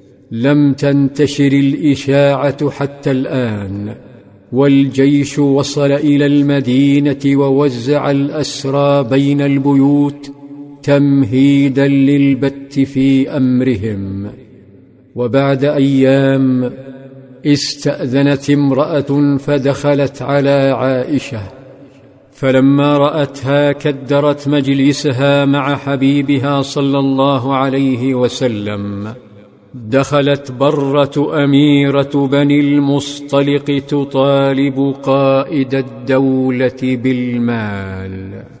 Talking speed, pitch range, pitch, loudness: 65 wpm, 130-140 Hz, 140 Hz, -13 LUFS